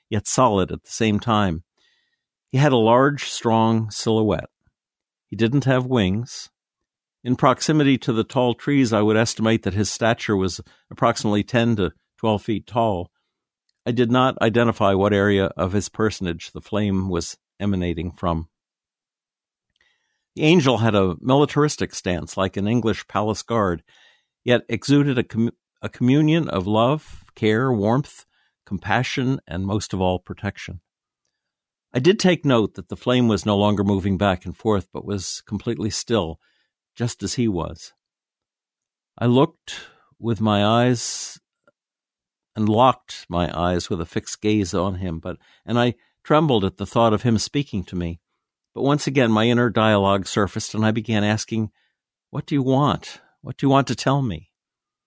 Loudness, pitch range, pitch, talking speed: -21 LUFS, 100-125 Hz, 110 Hz, 160 wpm